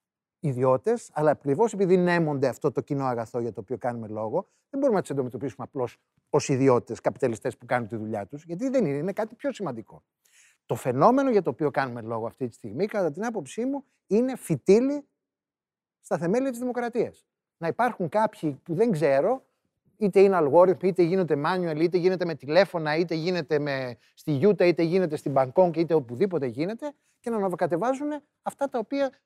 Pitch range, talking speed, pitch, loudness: 140-215 Hz, 180 wpm, 175 Hz, -26 LUFS